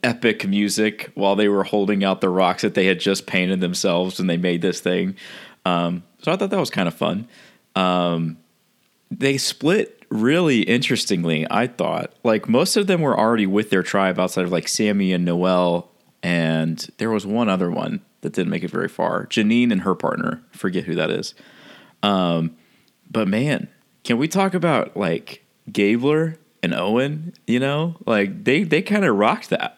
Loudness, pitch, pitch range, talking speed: -20 LUFS, 100 Hz, 90-135 Hz, 185 wpm